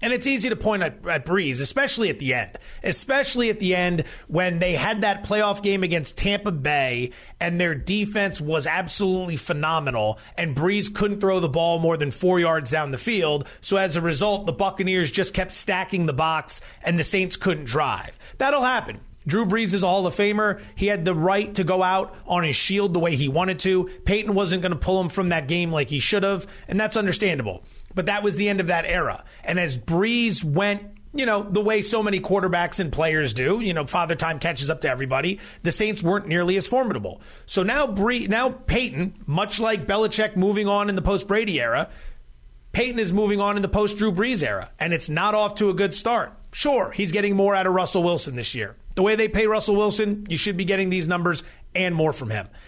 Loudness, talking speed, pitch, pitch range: -22 LUFS, 220 wpm, 190 Hz, 165-205 Hz